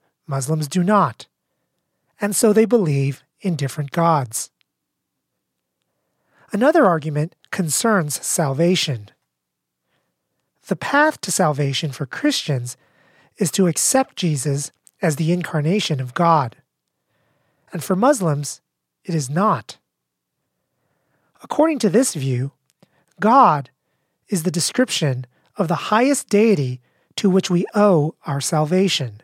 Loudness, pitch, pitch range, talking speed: -19 LUFS, 165 Hz, 140-205 Hz, 110 wpm